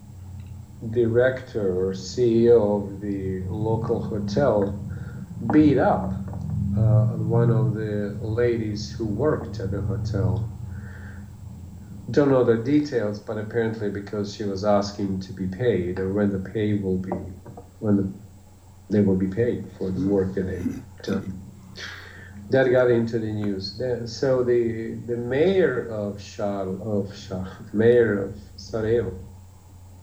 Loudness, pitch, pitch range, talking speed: -24 LUFS, 105 Hz, 95-115 Hz, 130 wpm